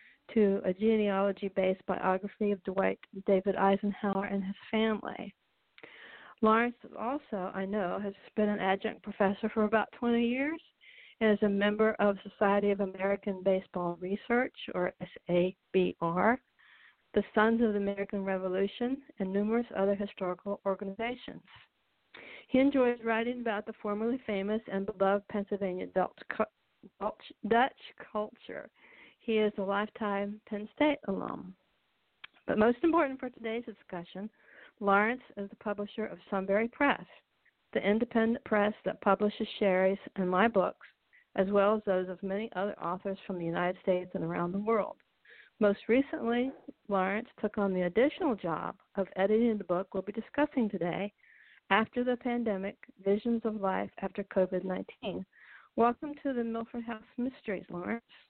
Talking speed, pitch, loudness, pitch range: 140 wpm, 205 Hz, -32 LUFS, 195-230 Hz